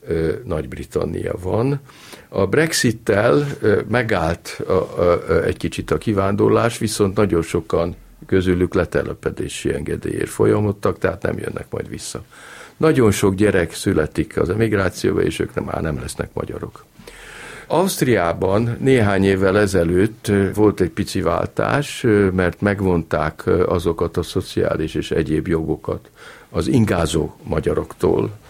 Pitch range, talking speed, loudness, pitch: 95-115 Hz, 115 wpm, -19 LUFS, 105 Hz